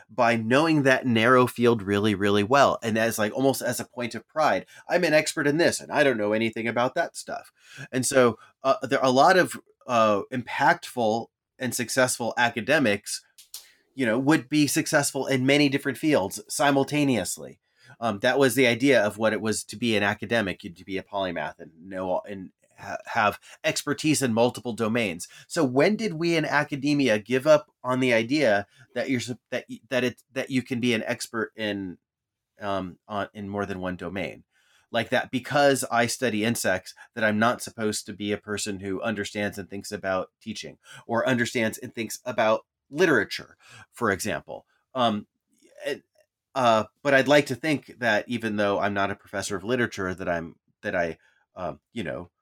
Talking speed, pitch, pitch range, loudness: 185 wpm, 120 Hz, 105-135 Hz, -25 LUFS